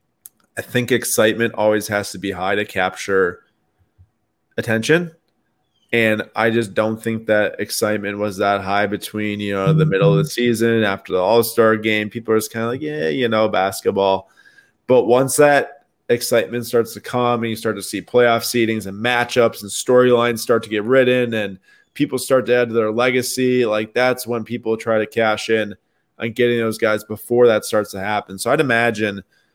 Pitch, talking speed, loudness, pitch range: 110 Hz, 195 wpm, -18 LUFS, 105-120 Hz